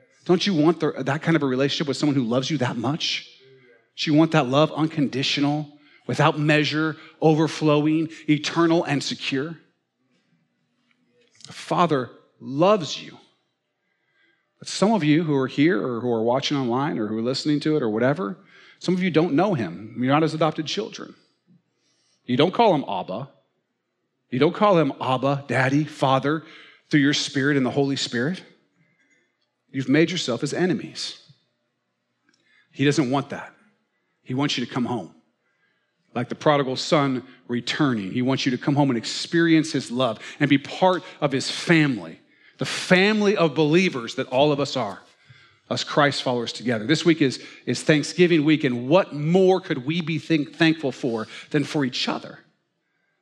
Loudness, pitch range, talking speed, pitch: -22 LUFS, 130-160 Hz, 170 wpm, 145 Hz